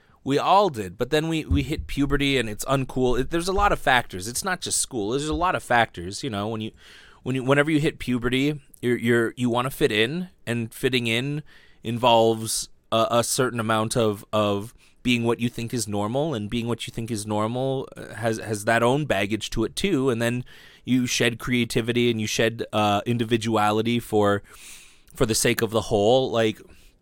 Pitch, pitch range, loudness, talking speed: 120 Hz, 110-130 Hz, -24 LUFS, 205 wpm